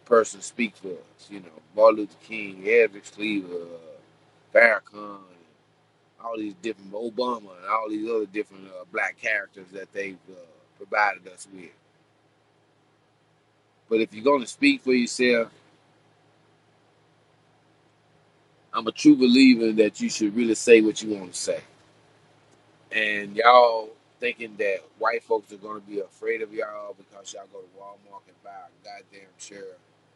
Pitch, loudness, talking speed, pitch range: 110 Hz, -23 LUFS, 145 wpm, 100-135 Hz